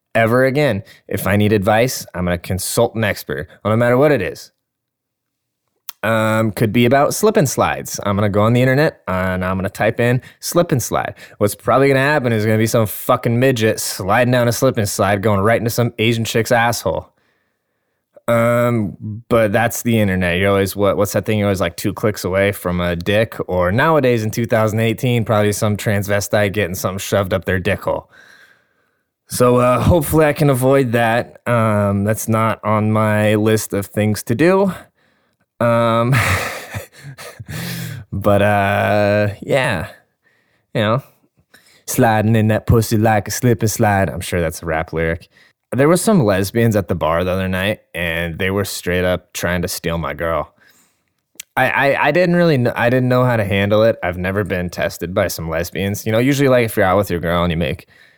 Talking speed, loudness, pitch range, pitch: 190 wpm, -16 LUFS, 100-120 Hz, 110 Hz